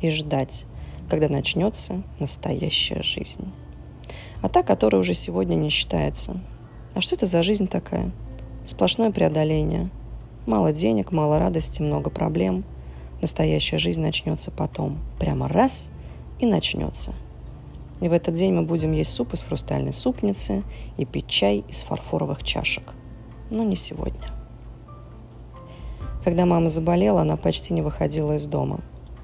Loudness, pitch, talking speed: -22 LUFS, 120 Hz, 130 wpm